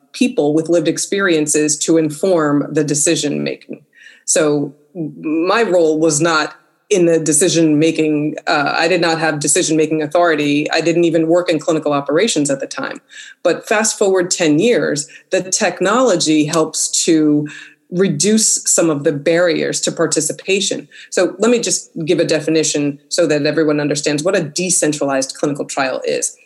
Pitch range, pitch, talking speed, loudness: 150-180 Hz, 160 Hz, 155 wpm, -15 LUFS